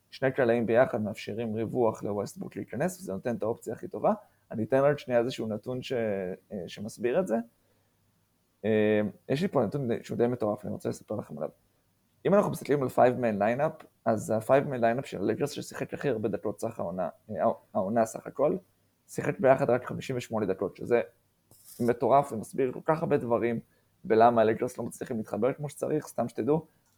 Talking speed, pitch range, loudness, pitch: 180 wpm, 110-130 Hz, -29 LUFS, 115 Hz